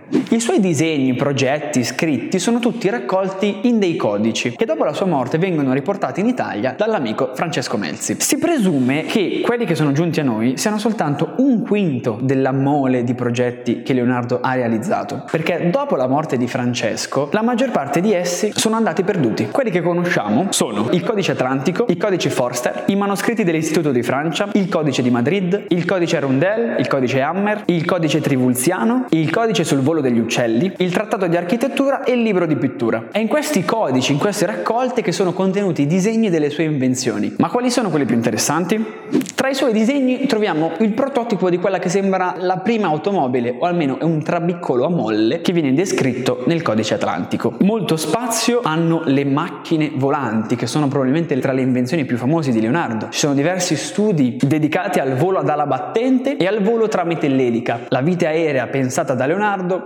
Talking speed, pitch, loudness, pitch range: 185 wpm, 170 Hz, -18 LUFS, 135-210 Hz